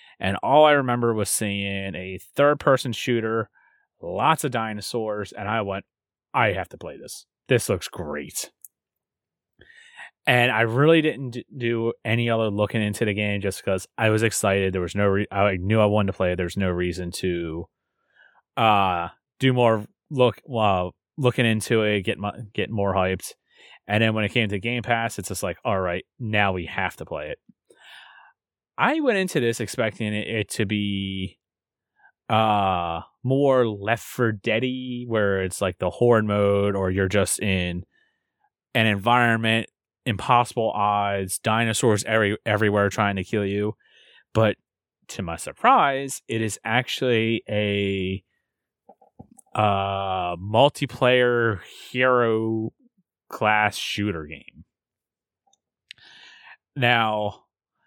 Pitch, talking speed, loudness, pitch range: 110 Hz, 140 wpm, -23 LUFS, 100-120 Hz